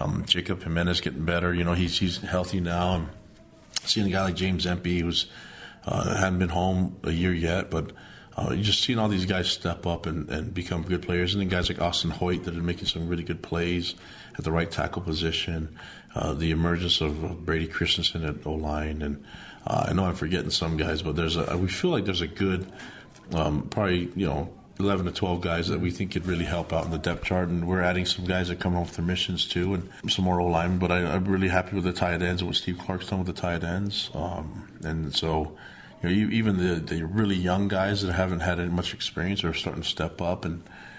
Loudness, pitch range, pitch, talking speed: -27 LUFS, 85-95 Hz, 90 Hz, 235 wpm